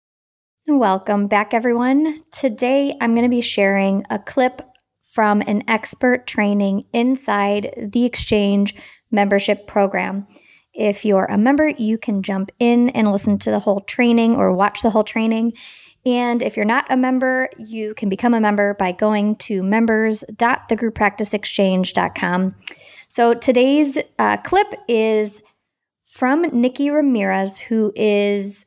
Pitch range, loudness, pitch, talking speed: 205-245 Hz, -18 LUFS, 220 Hz, 135 wpm